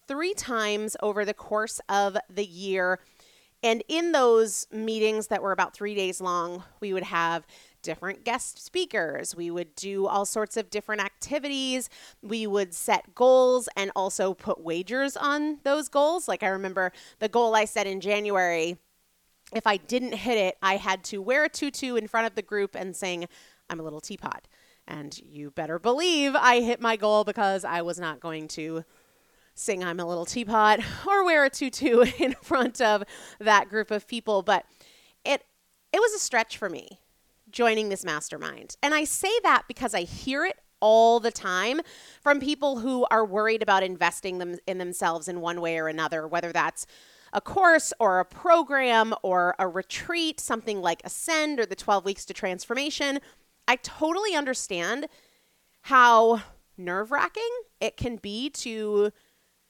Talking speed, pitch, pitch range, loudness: 170 wpm, 215 Hz, 185-255 Hz, -26 LUFS